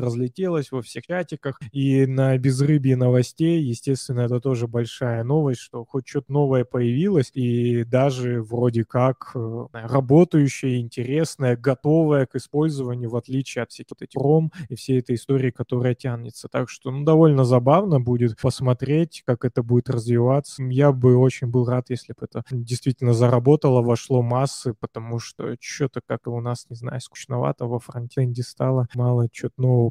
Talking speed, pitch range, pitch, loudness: 155 wpm, 120-135 Hz, 125 Hz, -22 LUFS